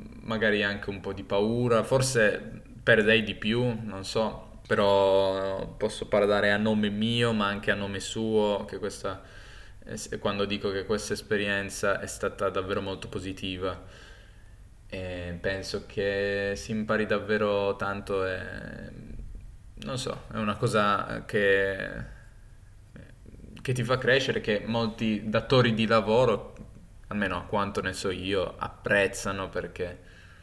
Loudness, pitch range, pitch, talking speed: -27 LUFS, 95-110 Hz, 100 Hz, 130 wpm